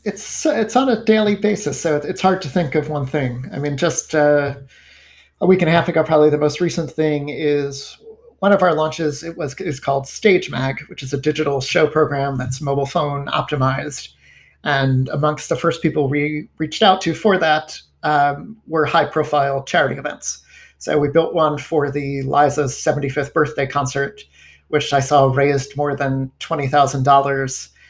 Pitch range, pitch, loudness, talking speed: 140-160 Hz, 150 Hz, -18 LUFS, 180 wpm